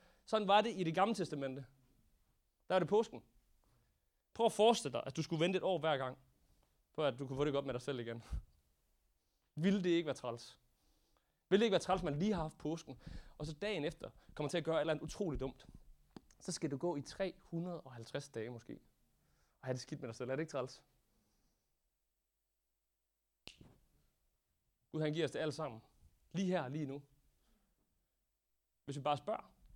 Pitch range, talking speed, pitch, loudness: 130-180 Hz, 200 wpm, 150 Hz, -39 LUFS